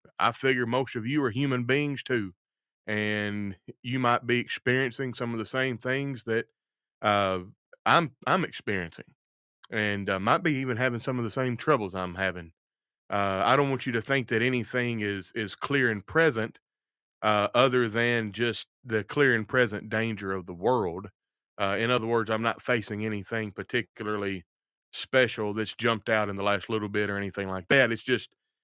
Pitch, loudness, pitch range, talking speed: 115 Hz, -28 LUFS, 105-125 Hz, 180 wpm